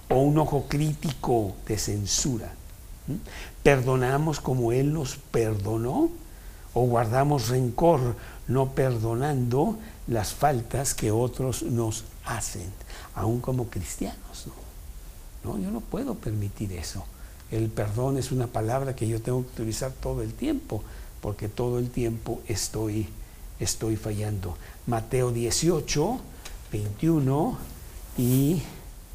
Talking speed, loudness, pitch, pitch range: 115 wpm, -27 LUFS, 115 Hz, 105-130 Hz